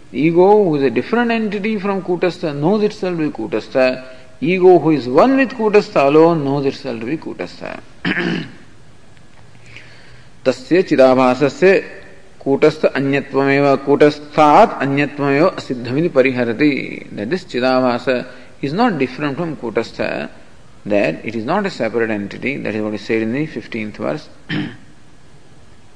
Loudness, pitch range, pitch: -16 LUFS, 130-175 Hz, 140 Hz